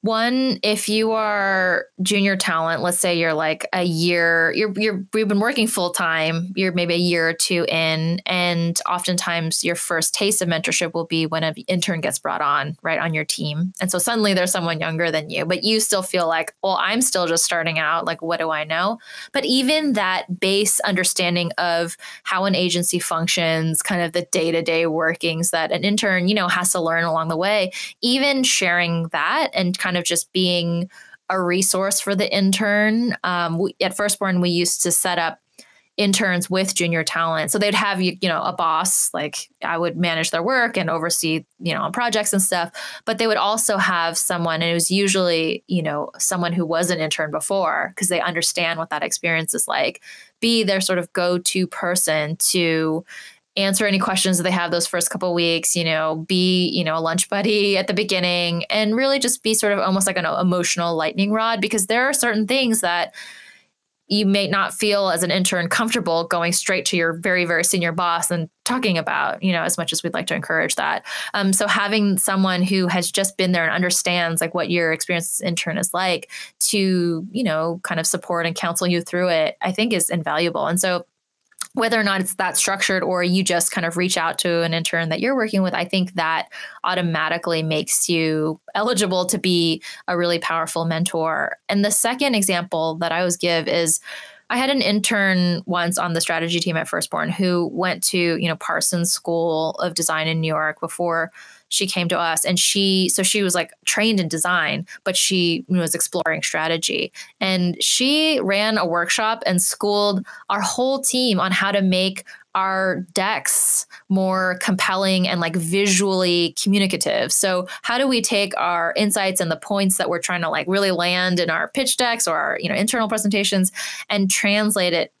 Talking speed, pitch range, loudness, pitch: 200 wpm, 170-200 Hz, -19 LUFS, 180 Hz